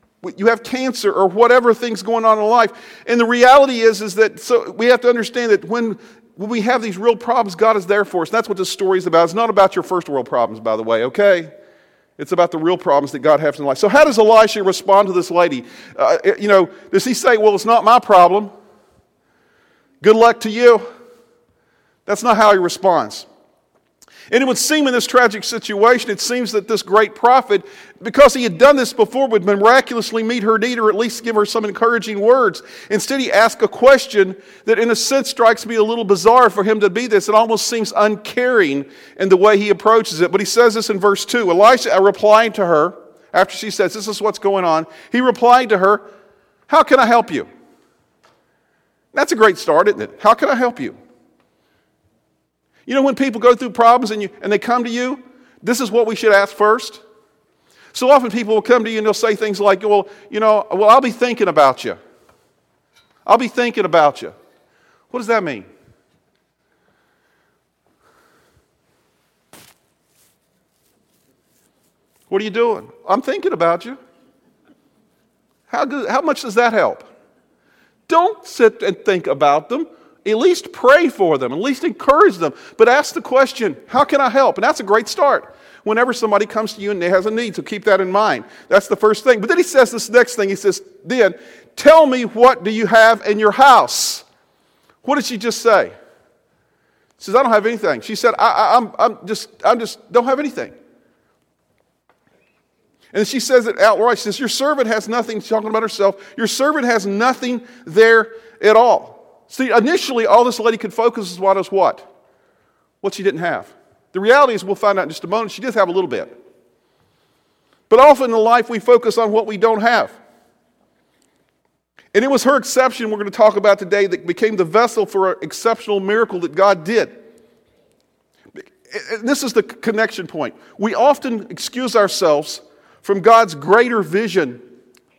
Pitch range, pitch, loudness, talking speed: 205-245 Hz, 225 Hz, -15 LUFS, 200 wpm